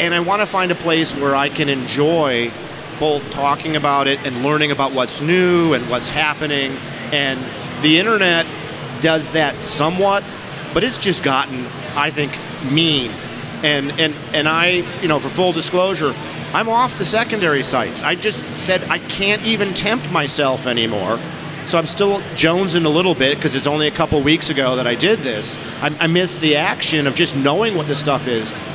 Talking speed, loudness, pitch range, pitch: 185 wpm, -17 LUFS, 140-170 Hz, 150 Hz